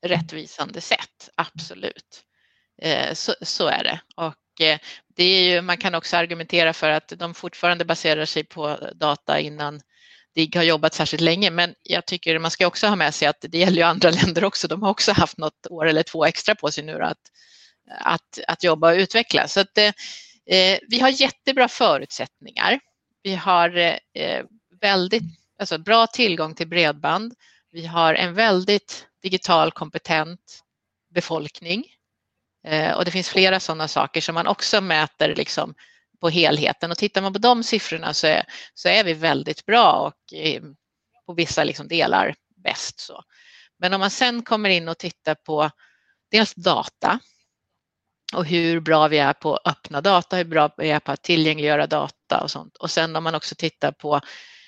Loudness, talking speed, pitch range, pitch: -20 LUFS, 170 wpm, 160-195 Hz, 170 Hz